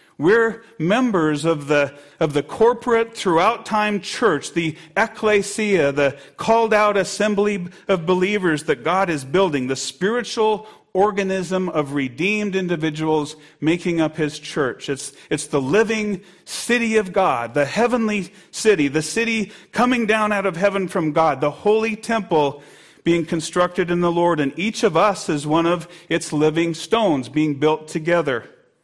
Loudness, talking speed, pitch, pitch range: -20 LUFS, 150 wpm, 180 Hz, 155-210 Hz